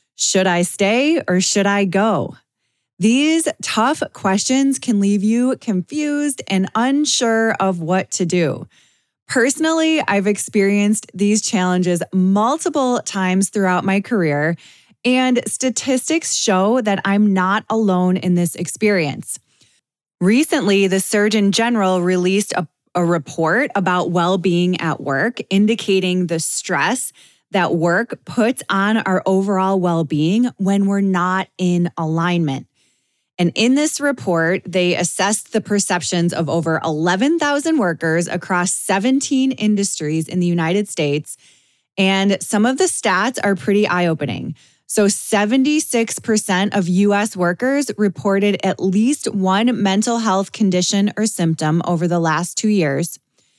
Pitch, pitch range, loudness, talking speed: 195 Hz, 175-220 Hz, -17 LUFS, 130 wpm